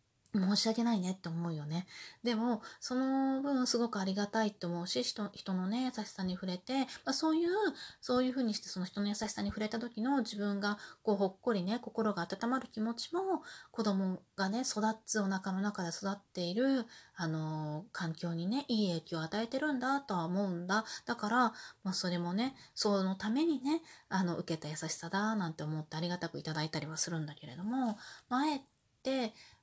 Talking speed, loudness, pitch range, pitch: 370 characters per minute, -36 LUFS, 180-245 Hz, 205 Hz